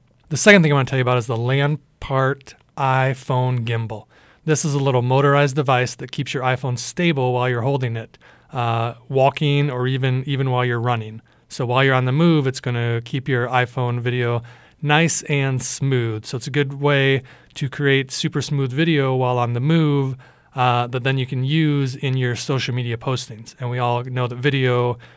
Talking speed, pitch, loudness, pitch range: 200 wpm, 130 Hz, -20 LUFS, 125-140 Hz